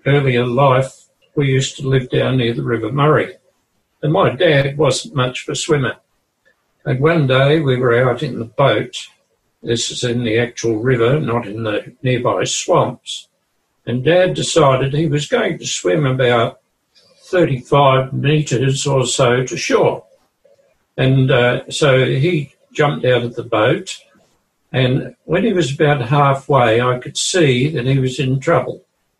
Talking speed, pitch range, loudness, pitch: 160 wpm, 125-145 Hz, -16 LUFS, 130 Hz